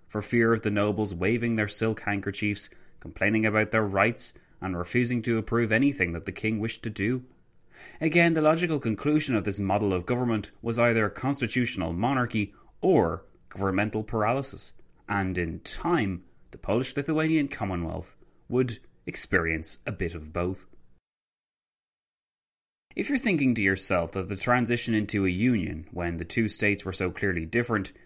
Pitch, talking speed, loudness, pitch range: 105 Hz, 155 wpm, -27 LUFS, 95-120 Hz